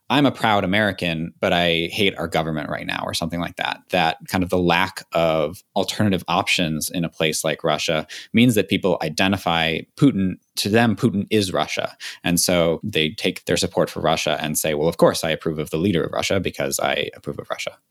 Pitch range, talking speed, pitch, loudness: 85-100 Hz, 210 wpm, 90 Hz, -21 LUFS